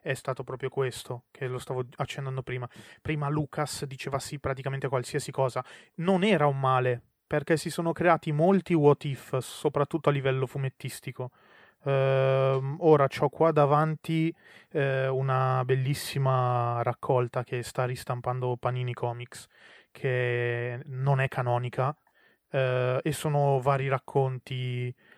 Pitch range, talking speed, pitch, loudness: 125-145 Hz, 130 wpm, 135 Hz, -28 LUFS